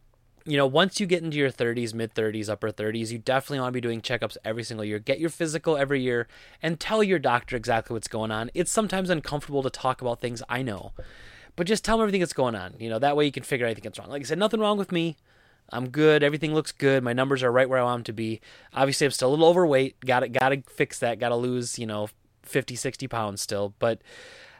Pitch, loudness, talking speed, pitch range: 130 Hz, -26 LUFS, 260 wpm, 115-150 Hz